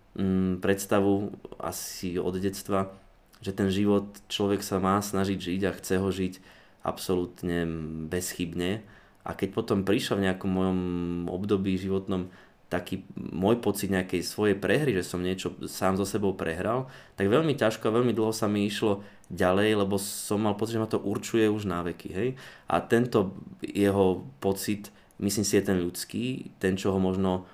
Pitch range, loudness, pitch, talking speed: 90-105 Hz, -28 LUFS, 95 Hz, 165 wpm